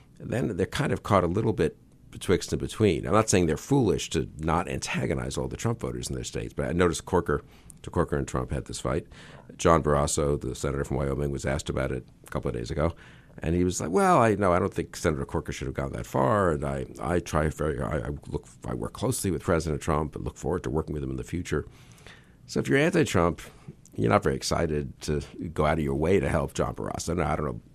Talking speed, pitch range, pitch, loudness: 250 wpm, 65-85 Hz, 75 Hz, -27 LUFS